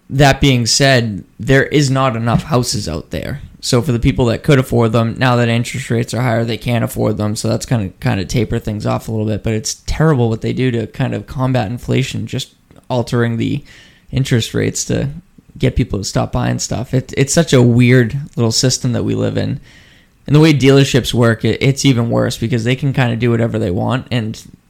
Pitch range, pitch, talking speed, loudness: 115-130 Hz, 120 Hz, 225 wpm, -15 LUFS